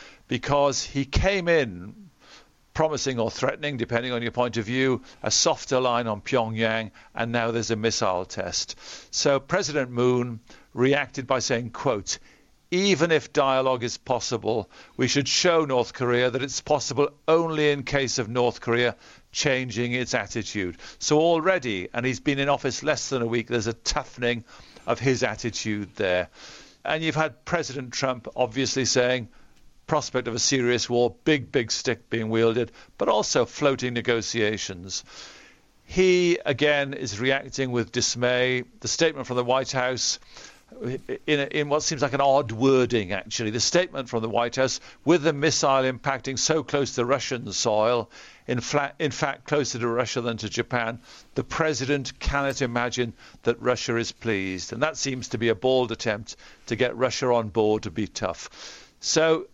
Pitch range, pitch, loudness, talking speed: 115-140 Hz, 125 Hz, -25 LUFS, 165 wpm